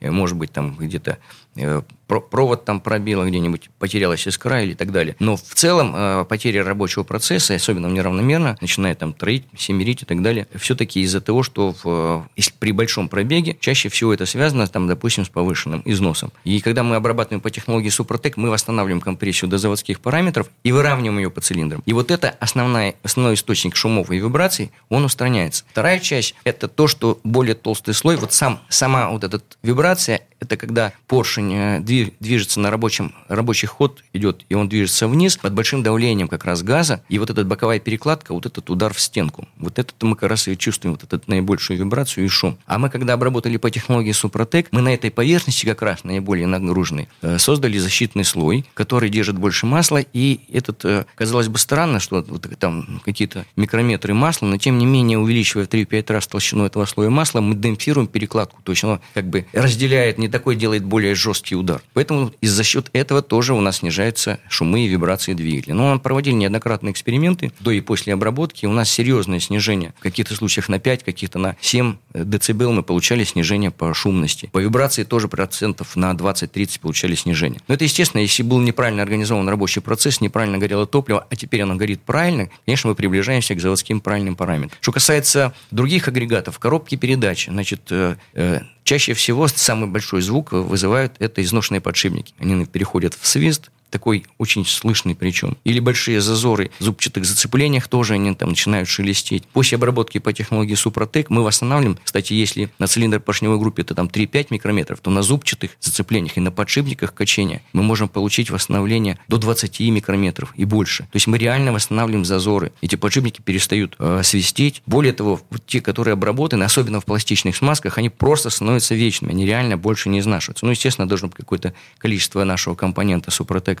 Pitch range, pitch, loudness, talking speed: 95-125 Hz, 110 Hz, -18 LUFS, 180 wpm